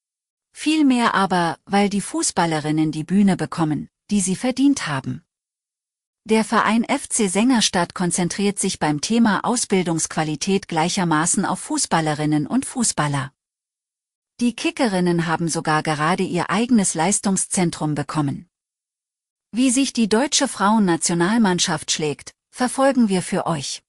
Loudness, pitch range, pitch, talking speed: -20 LUFS, 160-230 Hz, 190 Hz, 115 wpm